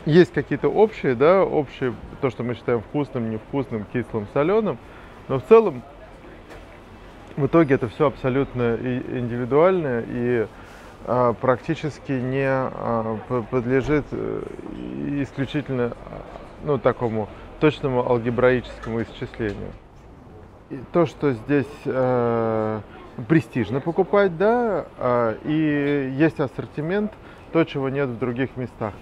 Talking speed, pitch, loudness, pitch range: 100 wpm, 130 Hz, -22 LUFS, 115-145 Hz